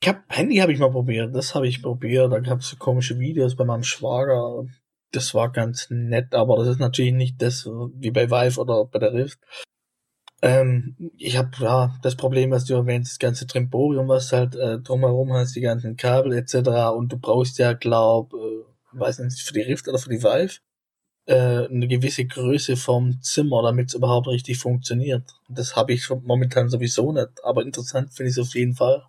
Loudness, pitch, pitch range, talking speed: -22 LUFS, 125 Hz, 120-130 Hz, 205 wpm